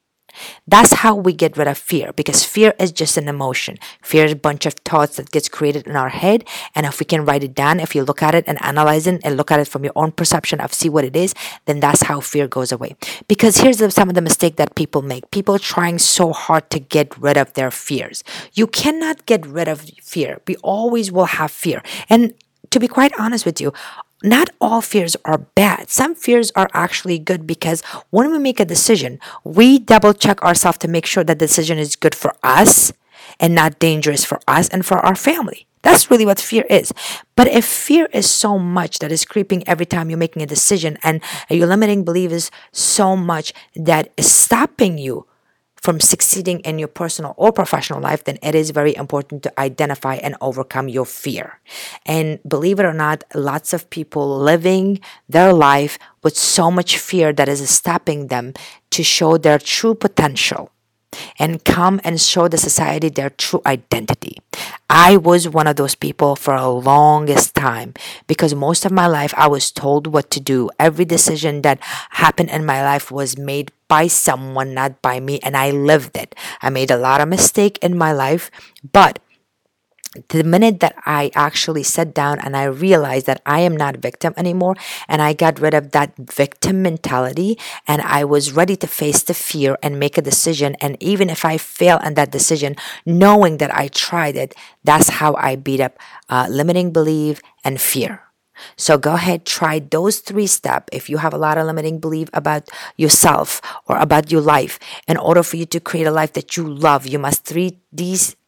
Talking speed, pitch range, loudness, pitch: 200 wpm, 145-180 Hz, -15 LUFS, 160 Hz